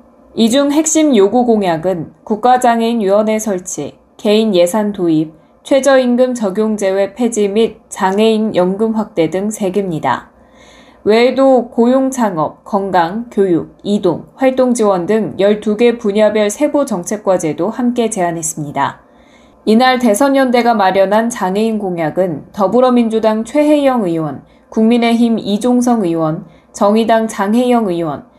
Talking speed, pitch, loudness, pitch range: 275 characters per minute, 215 Hz, -13 LUFS, 190-245 Hz